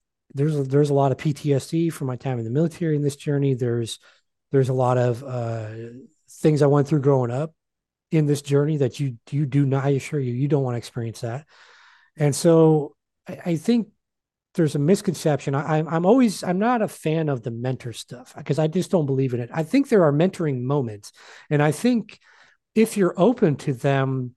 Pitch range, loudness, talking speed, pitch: 130-160 Hz, -22 LUFS, 210 wpm, 145 Hz